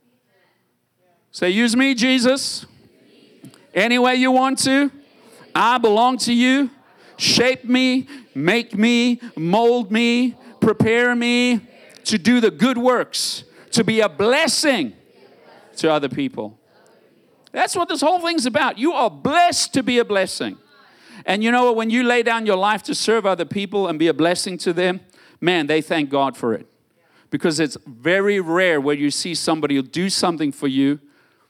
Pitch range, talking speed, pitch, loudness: 180-255 Hz, 165 wpm, 230 Hz, -18 LUFS